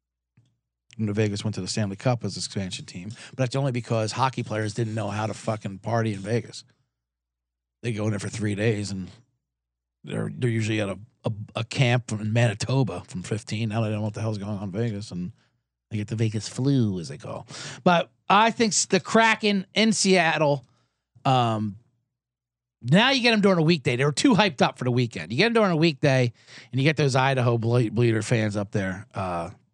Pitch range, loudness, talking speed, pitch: 105-135 Hz, -24 LUFS, 215 wpm, 120 Hz